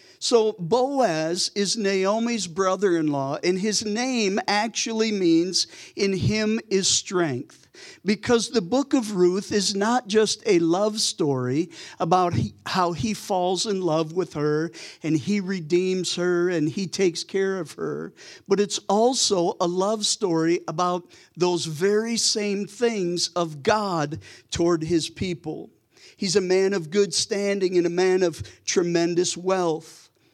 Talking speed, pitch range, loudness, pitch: 145 wpm, 170-210 Hz, -23 LUFS, 185 Hz